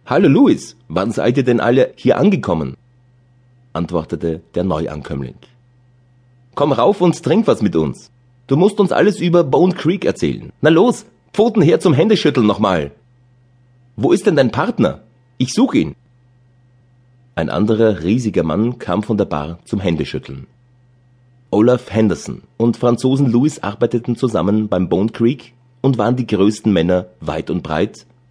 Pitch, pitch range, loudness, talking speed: 125 Hz, 100-125 Hz, -16 LUFS, 150 wpm